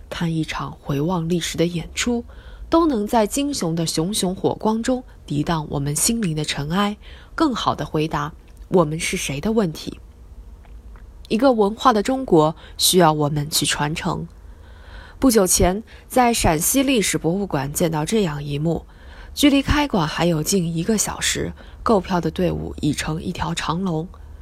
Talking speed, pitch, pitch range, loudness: 235 characters per minute, 165 Hz, 145-210 Hz, -20 LUFS